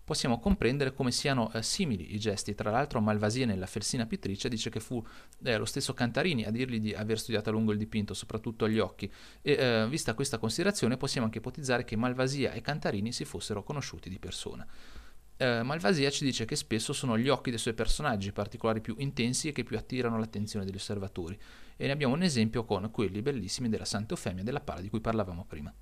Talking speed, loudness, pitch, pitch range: 205 wpm, -32 LUFS, 115 Hz, 105-130 Hz